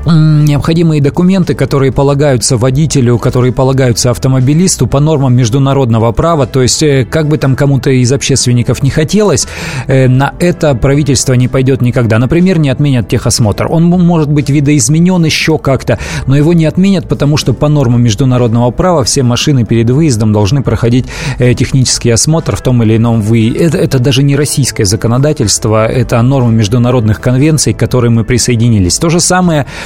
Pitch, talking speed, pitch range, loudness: 135 Hz, 155 wpm, 120-150 Hz, -9 LUFS